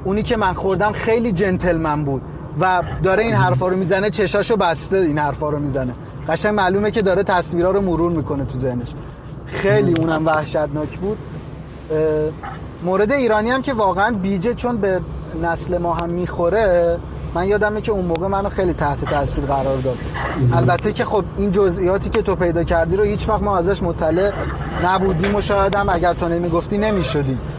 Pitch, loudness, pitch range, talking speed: 175 Hz, -18 LUFS, 155-200 Hz, 170 wpm